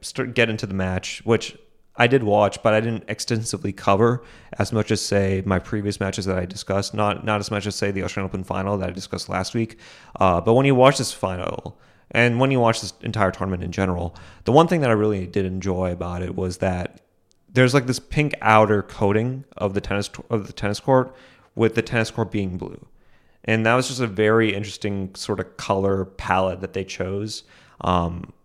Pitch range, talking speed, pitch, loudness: 95-115 Hz, 210 wpm, 105 Hz, -22 LUFS